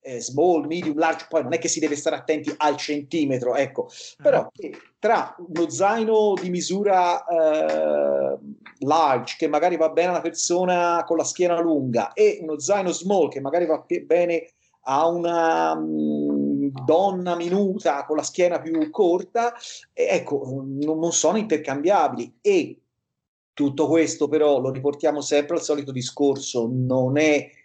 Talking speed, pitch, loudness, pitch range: 145 wpm, 160 Hz, -22 LUFS, 140-180 Hz